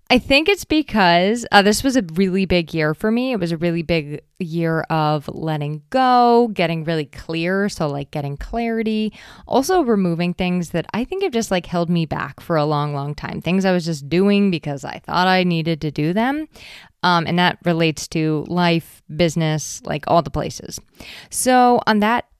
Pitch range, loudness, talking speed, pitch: 160-215 Hz, -19 LUFS, 195 wpm, 175 Hz